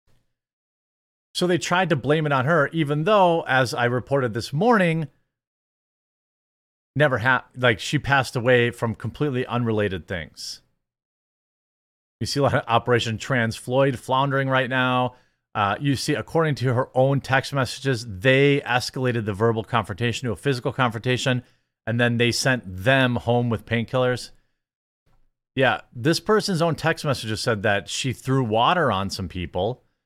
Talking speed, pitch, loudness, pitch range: 150 wpm, 125 Hz, -22 LUFS, 115-140 Hz